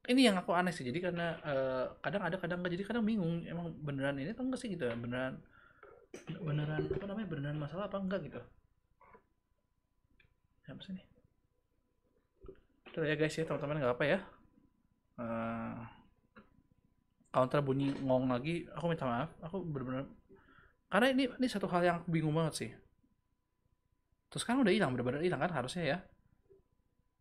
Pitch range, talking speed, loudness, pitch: 130-185 Hz, 160 wpm, -36 LUFS, 155 Hz